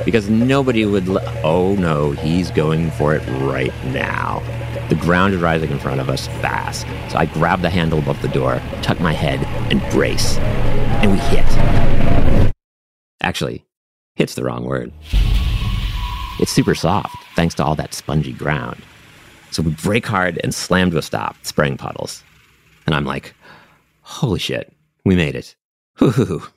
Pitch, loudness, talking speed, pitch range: 80 Hz, -19 LUFS, 160 wpm, 70-95 Hz